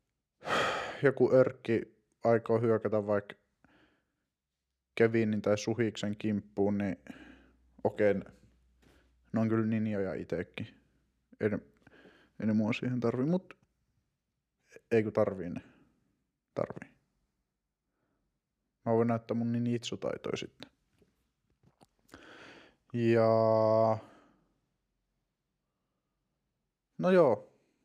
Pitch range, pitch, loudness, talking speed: 95-115 Hz, 110 Hz, -31 LUFS, 85 wpm